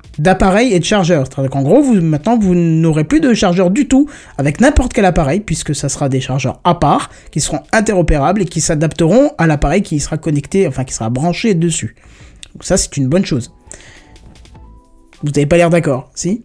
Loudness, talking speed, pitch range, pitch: -13 LUFS, 200 wpm, 145-190 Hz, 165 Hz